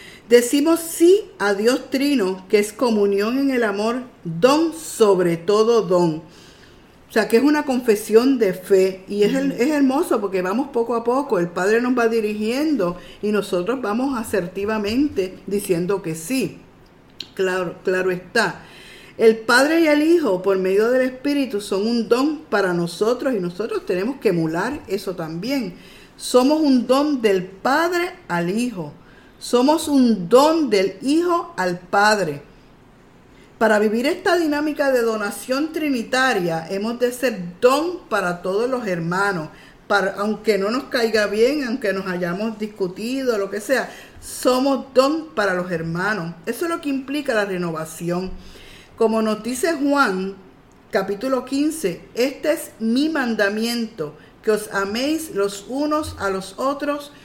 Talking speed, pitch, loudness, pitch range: 150 wpm, 225 Hz, -20 LUFS, 195-270 Hz